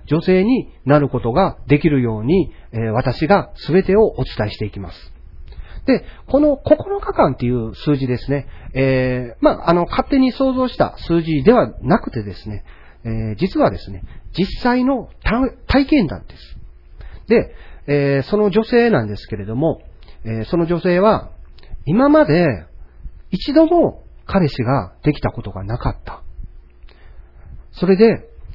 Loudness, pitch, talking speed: -17 LUFS, 135 Hz, 265 characters per minute